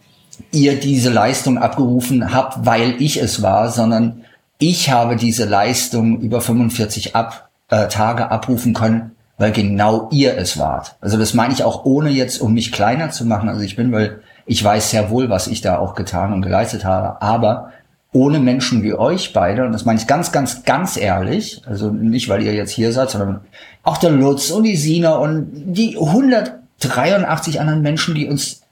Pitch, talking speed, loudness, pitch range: 120 Hz, 185 wpm, -16 LUFS, 110-140 Hz